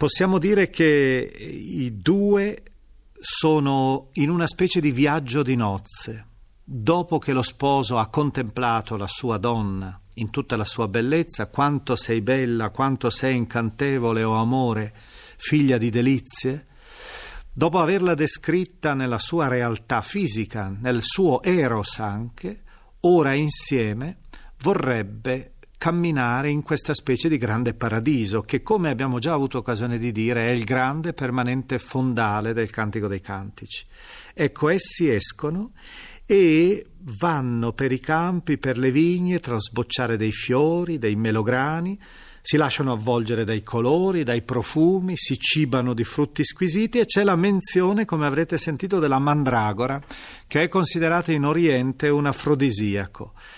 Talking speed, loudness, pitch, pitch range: 135 wpm, -22 LUFS, 135 Hz, 115-160 Hz